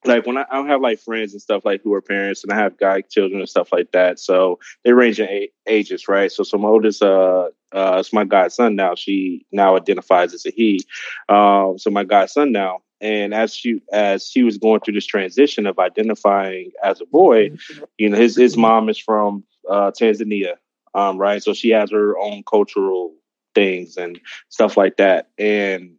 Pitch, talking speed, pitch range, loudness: 100 Hz, 205 wpm, 95-110 Hz, -17 LUFS